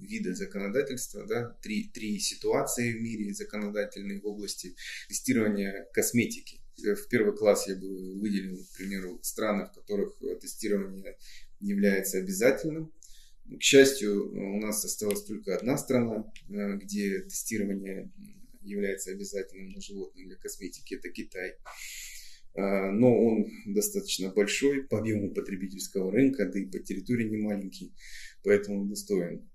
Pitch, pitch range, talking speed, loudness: 105 Hz, 100-140 Hz, 125 wpm, -30 LUFS